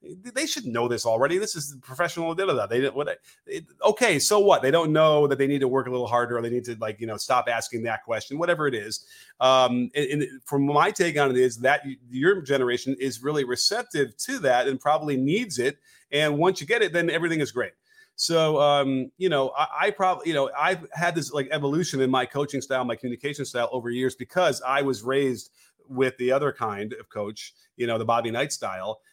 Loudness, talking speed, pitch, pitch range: -24 LUFS, 235 wpm, 140 Hz, 125-165 Hz